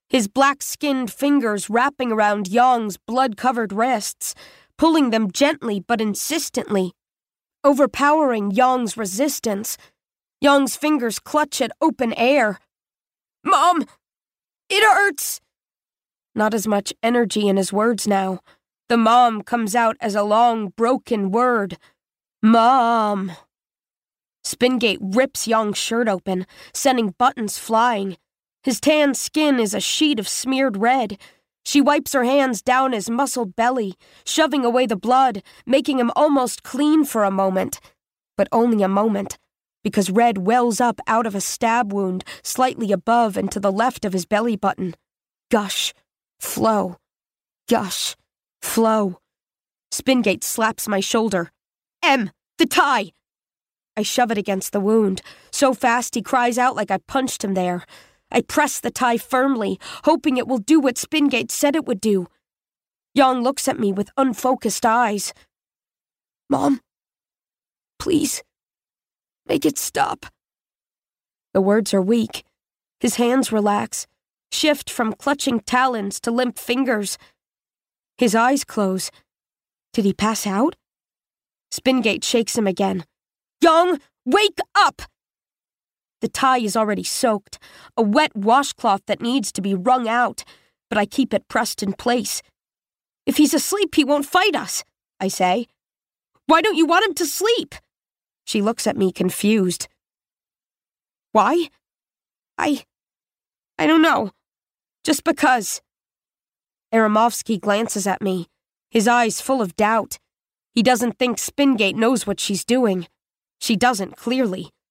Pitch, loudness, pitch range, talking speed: 235 Hz, -19 LUFS, 210-270 Hz, 135 wpm